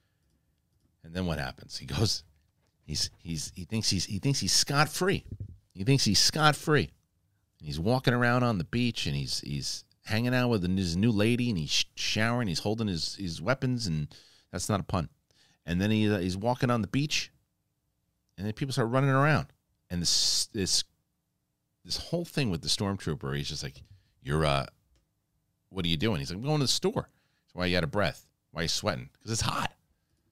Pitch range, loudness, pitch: 85-120 Hz, -29 LUFS, 100 Hz